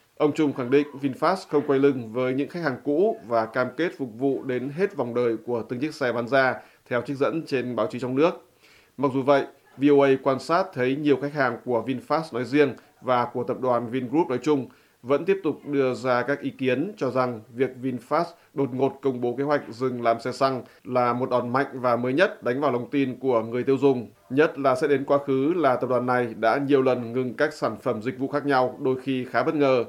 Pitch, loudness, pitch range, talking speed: 130 Hz, -24 LUFS, 125-145 Hz, 240 wpm